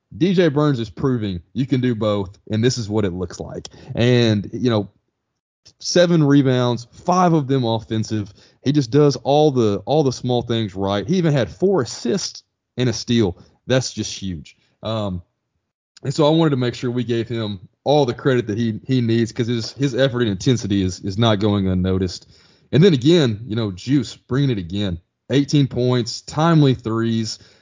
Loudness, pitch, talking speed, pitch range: -19 LUFS, 120 Hz, 190 wpm, 105-135 Hz